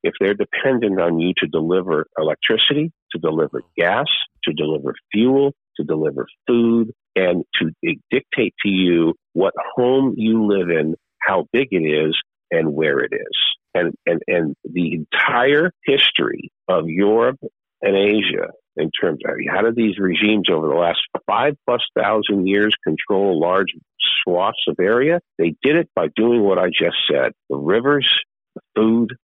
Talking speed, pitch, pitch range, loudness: 160 wpm, 105 Hz, 90-120 Hz, -18 LUFS